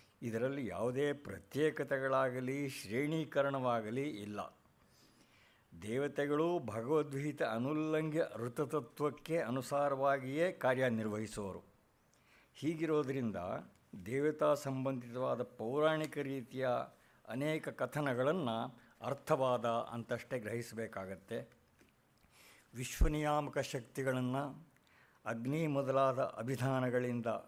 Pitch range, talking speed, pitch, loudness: 120-145 Hz, 55 wpm, 135 Hz, -37 LUFS